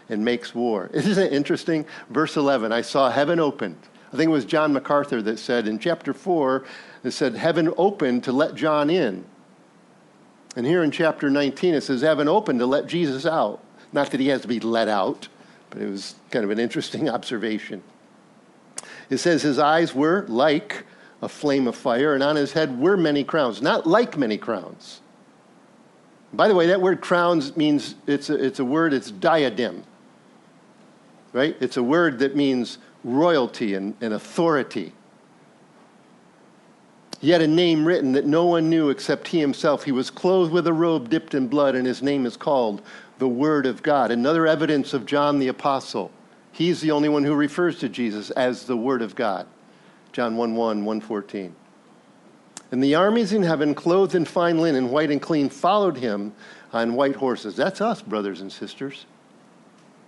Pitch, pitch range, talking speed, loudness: 145 Hz, 125-165 Hz, 180 wpm, -22 LUFS